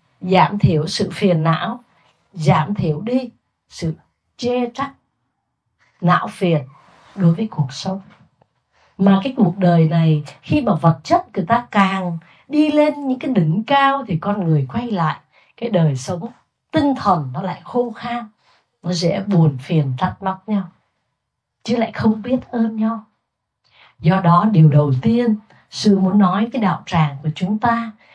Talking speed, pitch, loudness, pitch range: 160 wpm, 190 Hz, -18 LUFS, 160-225 Hz